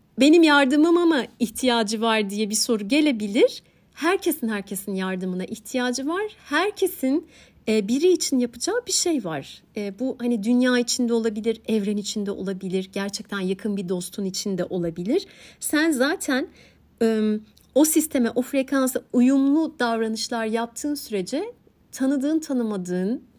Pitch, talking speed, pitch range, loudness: 240 Hz, 120 wpm, 210-290 Hz, -23 LUFS